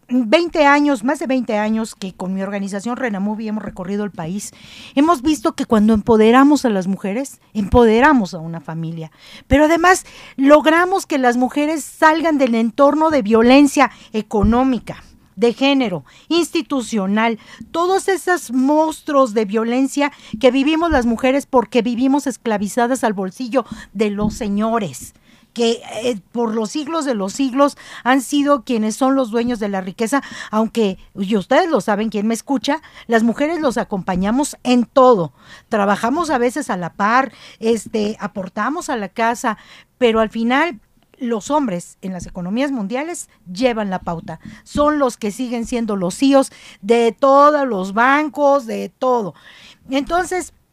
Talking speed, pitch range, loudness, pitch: 150 wpm, 215-280 Hz, -17 LUFS, 240 Hz